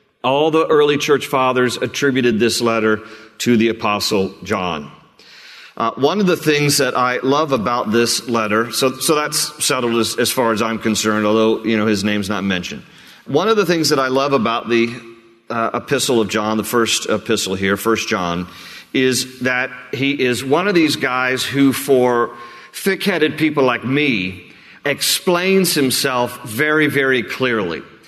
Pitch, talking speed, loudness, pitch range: 125 Hz, 165 wpm, -17 LUFS, 115-140 Hz